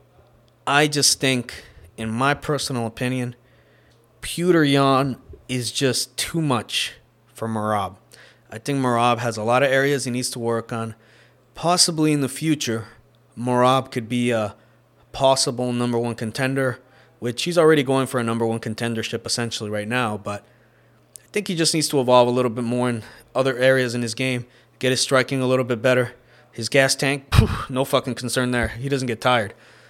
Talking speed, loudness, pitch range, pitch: 175 wpm, -21 LUFS, 115-135 Hz, 125 Hz